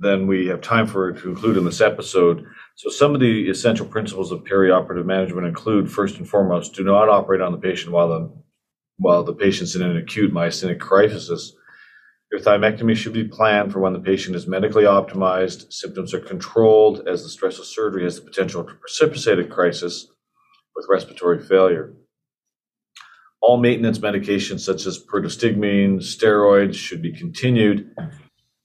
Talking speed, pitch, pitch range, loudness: 170 wpm, 100 Hz, 95-115 Hz, -19 LUFS